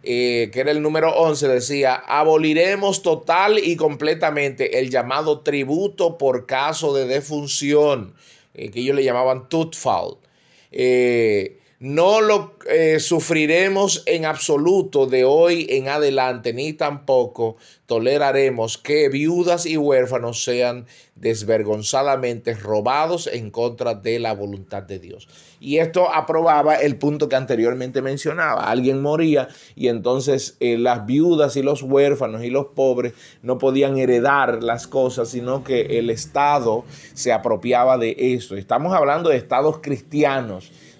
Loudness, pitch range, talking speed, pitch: -19 LUFS, 125-155 Hz, 135 wpm, 135 Hz